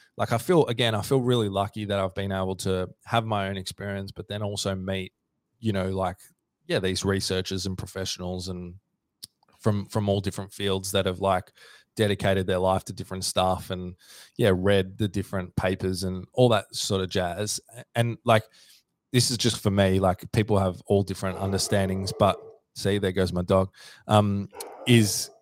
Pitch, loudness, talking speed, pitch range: 95 Hz, -26 LUFS, 180 wpm, 95-105 Hz